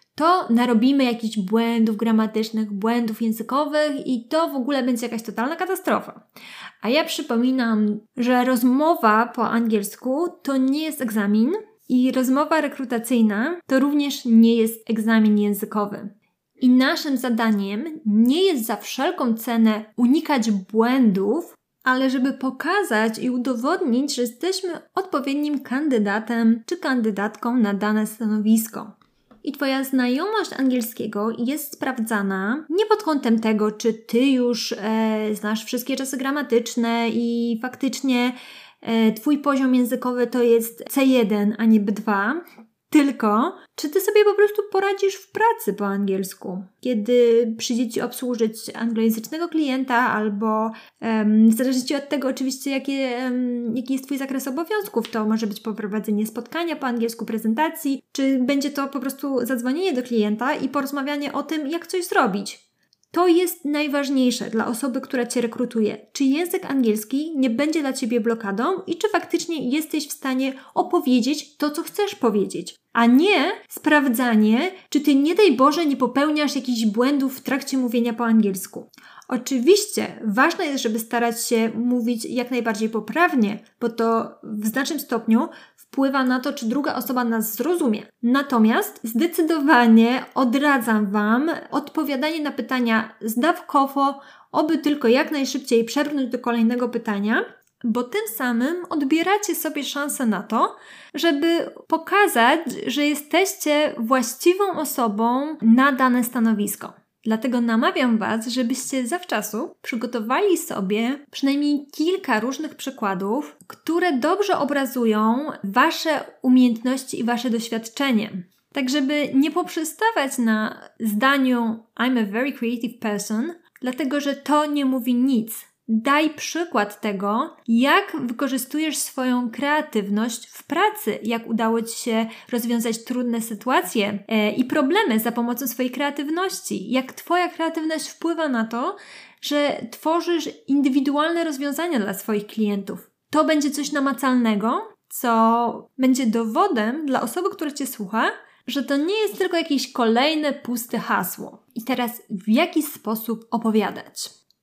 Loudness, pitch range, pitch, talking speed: -21 LUFS, 225-295 Hz, 255 Hz, 130 wpm